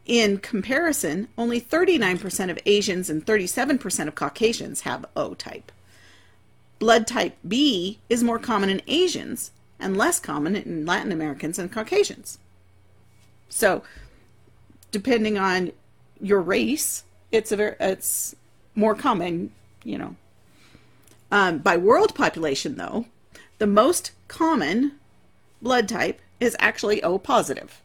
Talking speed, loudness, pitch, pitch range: 120 wpm, -23 LUFS, 210 Hz, 180-240 Hz